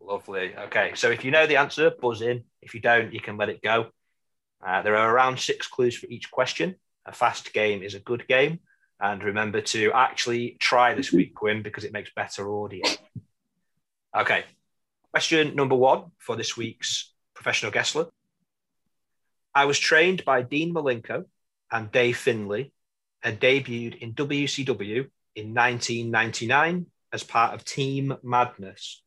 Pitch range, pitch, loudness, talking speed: 115-145 Hz, 125 Hz, -24 LUFS, 155 wpm